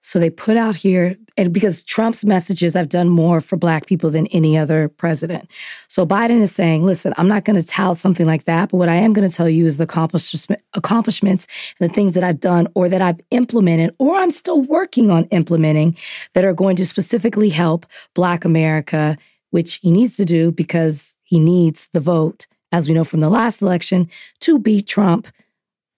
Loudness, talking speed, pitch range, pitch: -16 LUFS, 205 wpm, 165-205 Hz, 180 Hz